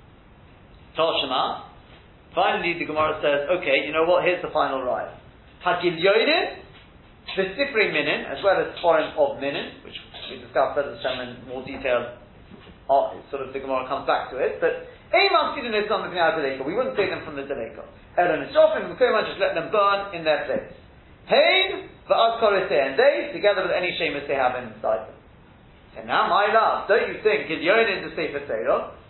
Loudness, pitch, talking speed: -22 LUFS, 180 Hz, 180 wpm